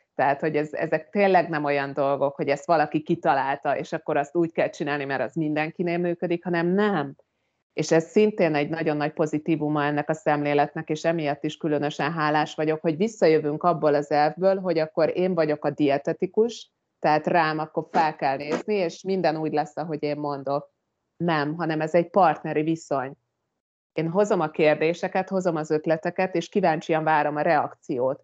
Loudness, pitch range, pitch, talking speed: -24 LUFS, 150-170 Hz, 155 Hz, 175 wpm